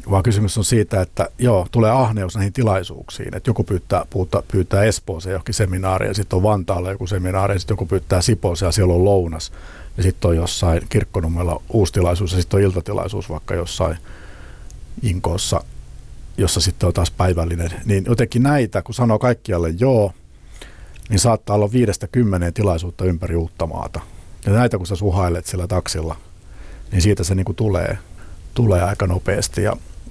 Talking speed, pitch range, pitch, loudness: 165 wpm, 90-105 Hz, 95 Hz, -19 LUFS